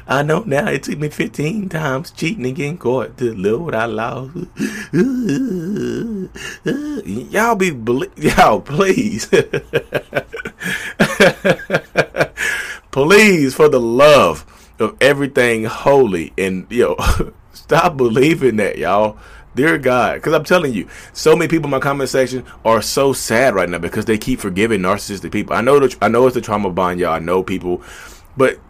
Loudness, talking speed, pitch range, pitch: -16 LUFS, 150 wpm, 105-155 Hz, 130 Hz